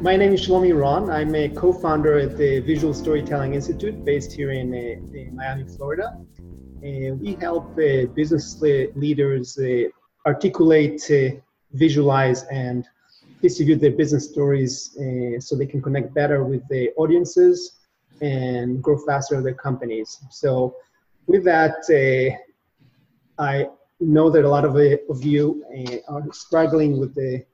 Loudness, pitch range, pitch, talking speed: -20 LUFS, 130-155 Hz, 145 Hz, 130 wpm